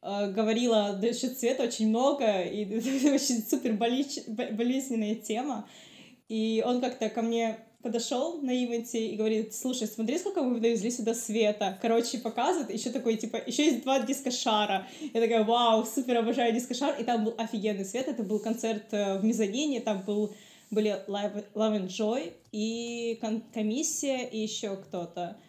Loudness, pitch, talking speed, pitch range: -30 LUFS, 230 Hz, 155 wpm, 220-250 Hz